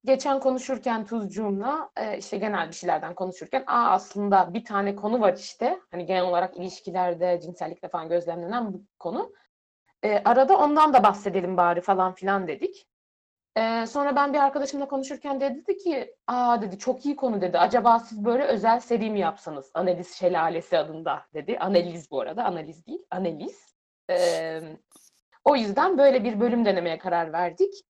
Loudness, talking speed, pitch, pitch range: -25 LUFS, 160 wpm, 210 Hz, 180-270 Hz